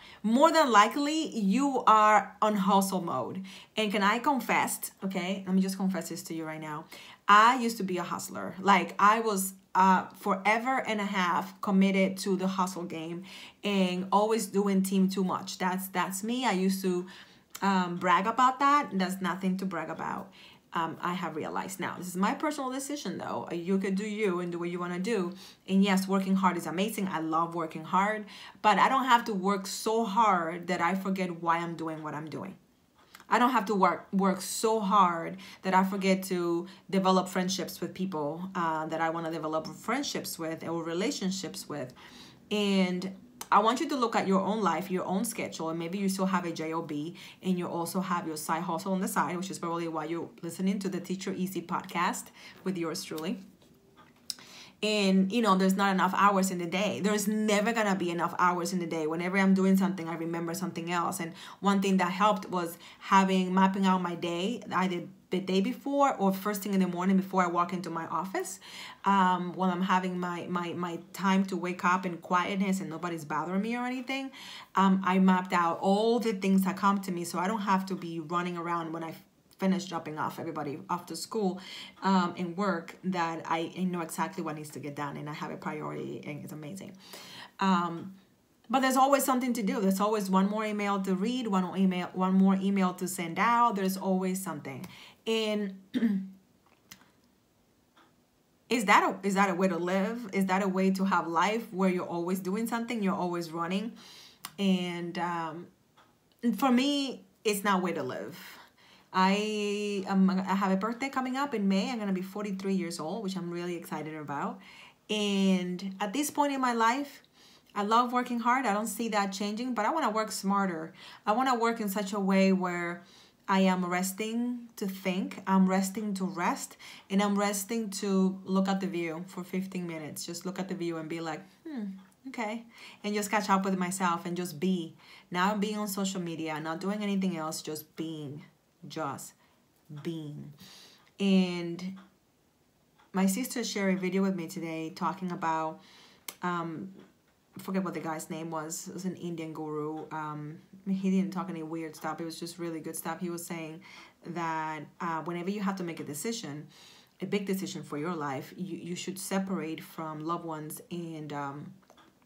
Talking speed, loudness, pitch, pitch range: 195 wpm, -30 LUFS, 190 Hz, 170-205 Hz